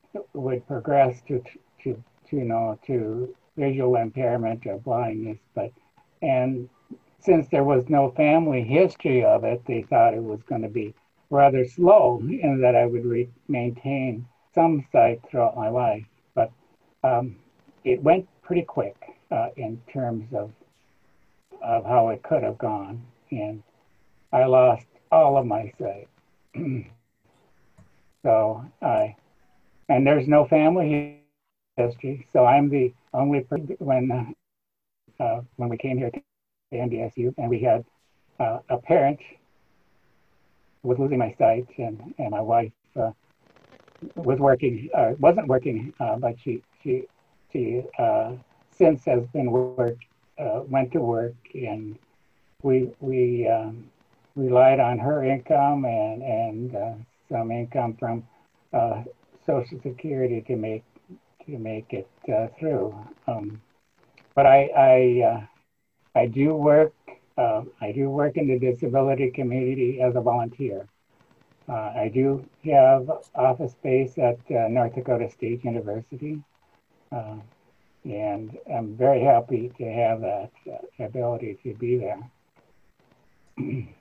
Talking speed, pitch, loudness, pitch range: 135 wpm, 125 Hz, -23 LUFS, 120-140 Hz